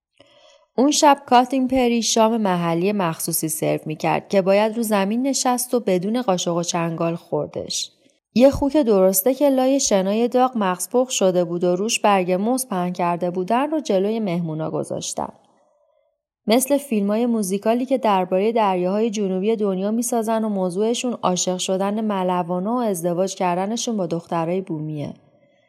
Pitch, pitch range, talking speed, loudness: 205 Hz, 185-245 Hz, 145 wpm, -20 LUFS